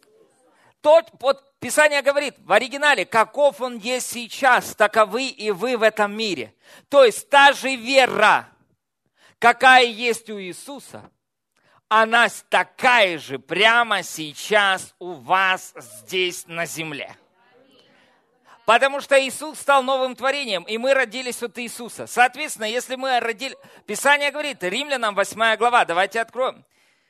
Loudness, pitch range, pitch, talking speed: -19 LUFS, 210-270 Hz, 240 Hz, 125 wpm